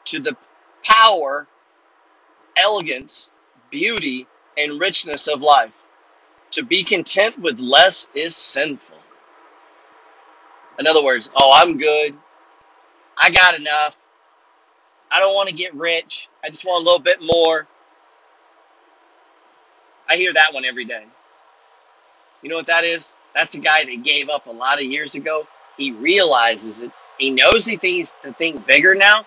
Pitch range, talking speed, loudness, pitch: 150-180 Hz, 145 wpm, -16 LUFS, 160 Hz